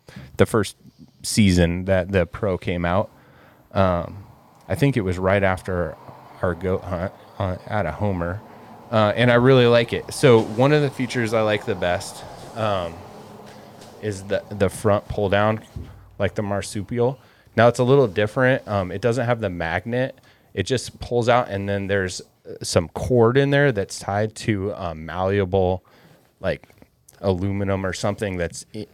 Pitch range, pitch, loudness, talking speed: 95-120 Hz, 105 Hz, -22 LUFS, 170 wpm